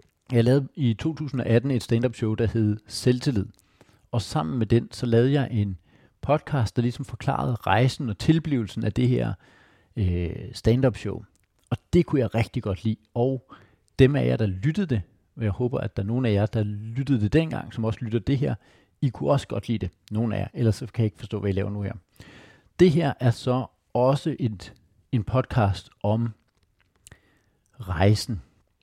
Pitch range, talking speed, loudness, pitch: 105-125 Hz, 190 wpm, -25 LUFS, 115 Hz